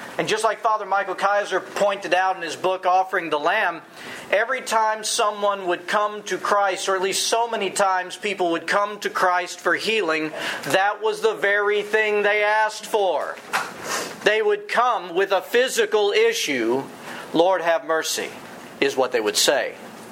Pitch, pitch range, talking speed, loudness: 200 Hz, 185-220 Hz, 170 wpm, -21 LUFS